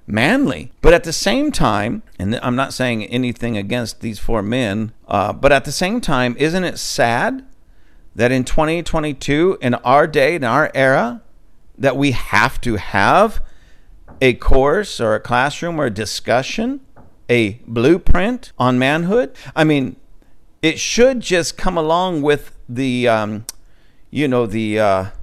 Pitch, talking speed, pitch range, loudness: 130 Hz, 150 wpm, 115-160 Hz, -17 LUFS